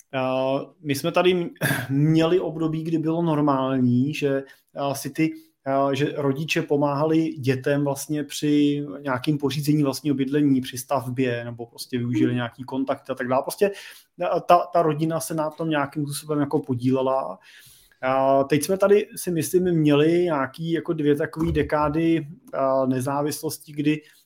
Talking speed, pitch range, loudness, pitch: 135 wpm, 135-160 Hz, -23 LUFS, 145 Hz